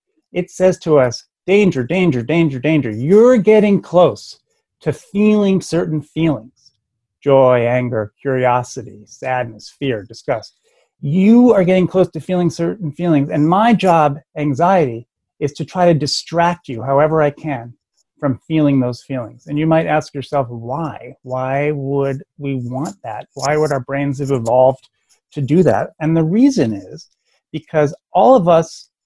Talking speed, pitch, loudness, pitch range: 155 wpm, 150 Hz, -16 LUFS, 130-175 Hz